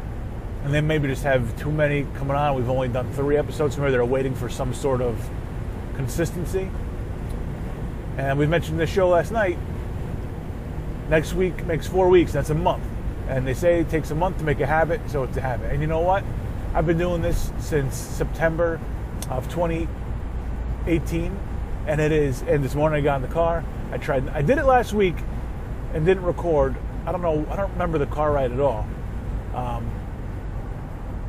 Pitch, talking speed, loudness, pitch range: 135 Hz, 190 wpm, -24 LUFS, 115-155 Hz